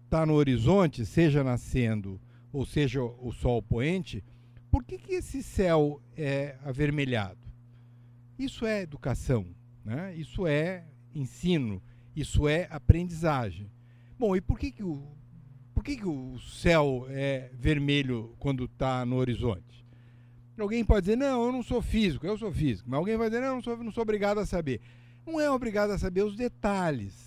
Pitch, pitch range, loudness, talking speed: 140 Hz, 120-185 Hz, -29 LUFS, 165 wpm